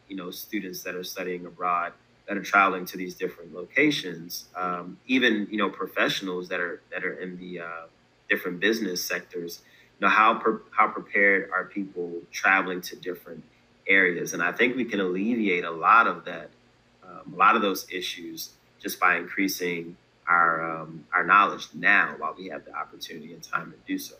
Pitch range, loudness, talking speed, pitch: 85-95 Hz, -25 LUFS, 185 wpm, 90 Hz